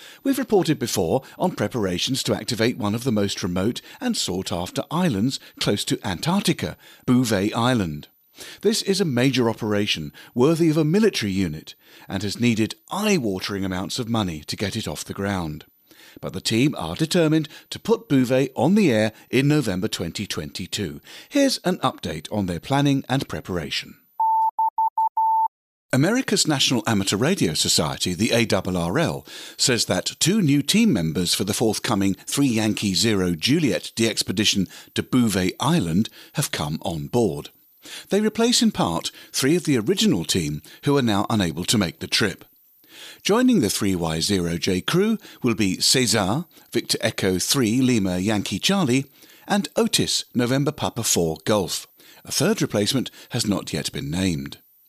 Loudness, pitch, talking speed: -22 LUFS, 115 Hz, 155 wpm